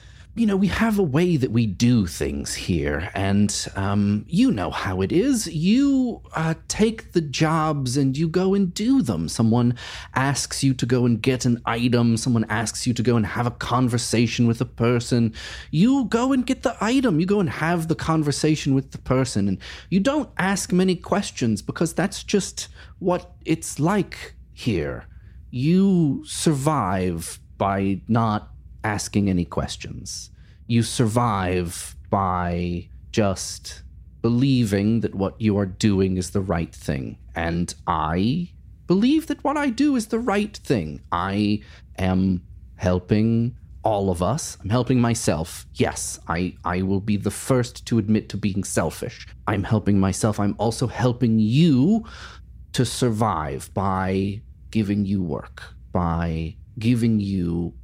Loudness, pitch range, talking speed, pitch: -22 LUFS, 95-155 Hz, 150 wpm, 115 Hz